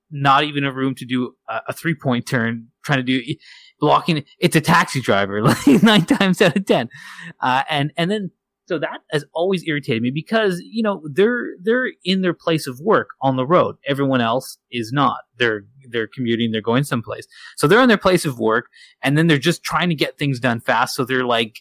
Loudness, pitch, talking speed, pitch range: -19 LUFS, 145 Hz, 210 wpm, 125-175 Hz